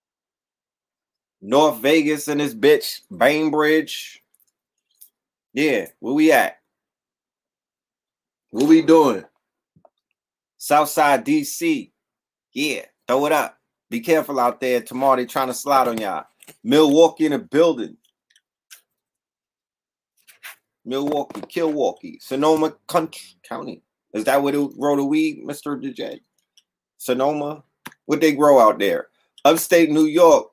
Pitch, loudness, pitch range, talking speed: 150 Hz, -19 LUFS, 140-170 Hz, 110 wpm